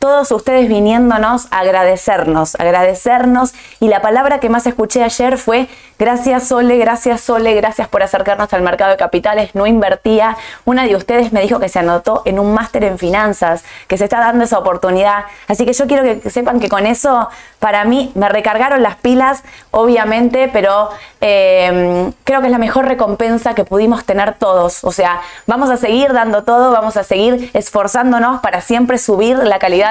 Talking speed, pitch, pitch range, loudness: 180 wpm, 220 Hz, 200-245 Hz, -12 LUFS